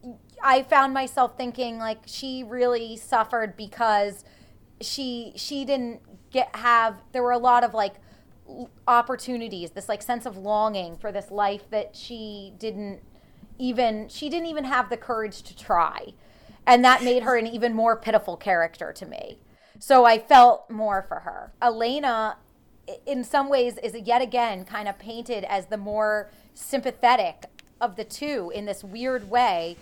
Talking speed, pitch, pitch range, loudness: 160 wpm, 235 Hz, 215-250 Hz, -23 LUFS